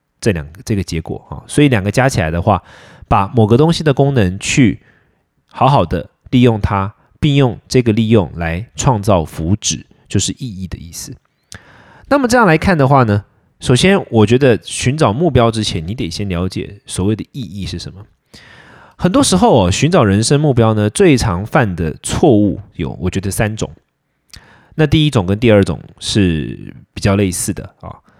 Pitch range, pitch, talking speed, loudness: 95-130 Hz, 105 Hz, 265 characters per minute, -14 LUFS